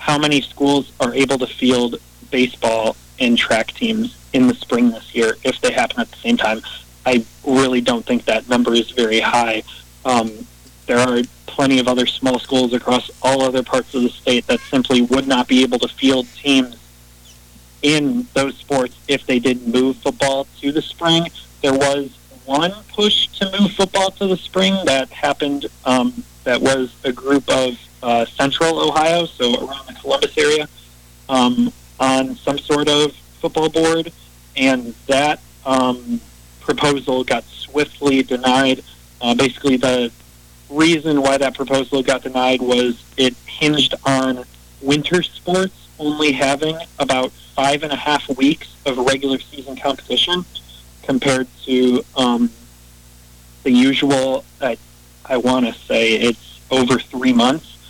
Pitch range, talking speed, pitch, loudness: 120-145 Hz, 155 wpm, 130 Hz, -17 LUFS